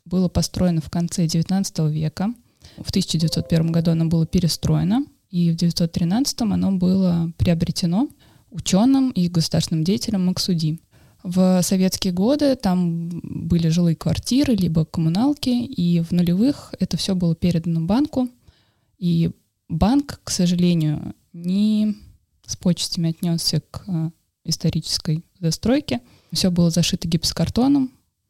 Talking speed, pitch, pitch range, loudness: 115 wpm, 175 Hz, 165-195 Hz, -21 LUFS